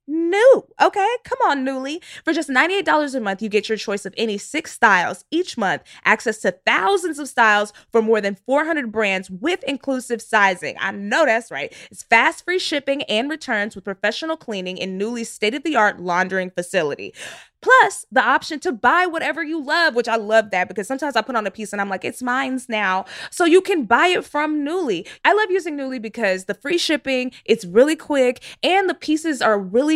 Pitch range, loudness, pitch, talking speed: 215-325 Hz, -19 LUFS, 260 Hz, 205 wpm